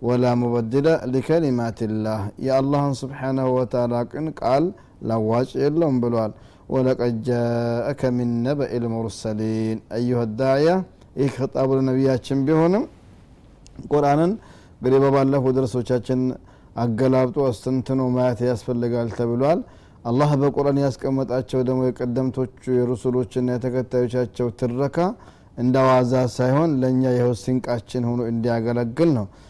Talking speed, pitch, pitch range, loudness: 95 wpm, 125 Hz, 120-135 Hz, -22 LUFS